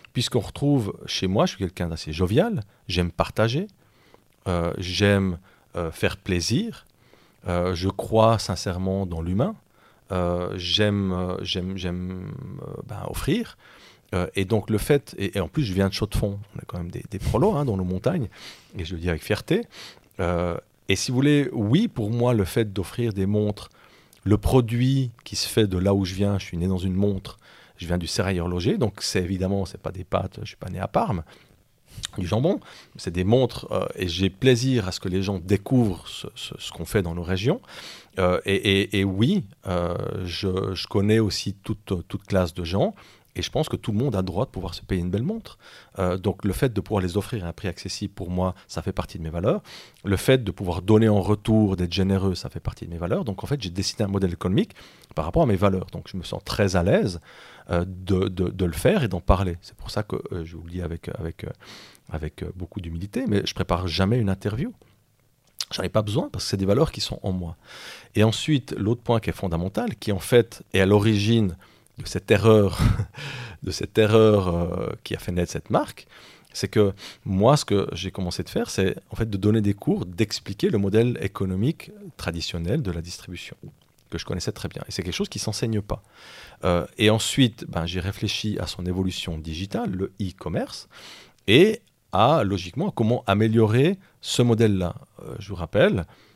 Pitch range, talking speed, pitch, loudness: 90-110 Hz, 215 wpm, 100 Hz, -24 LUFS